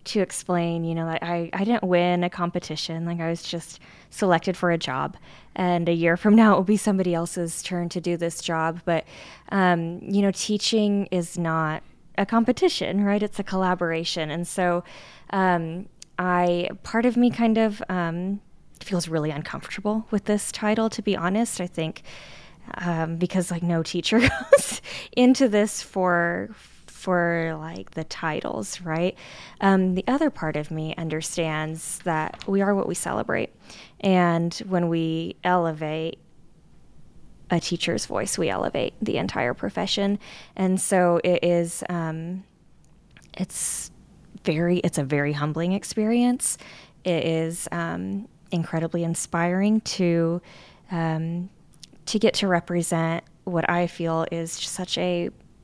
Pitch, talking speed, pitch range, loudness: 175 Hz, 145 wpm, 165-195 Hz, -24 LUFS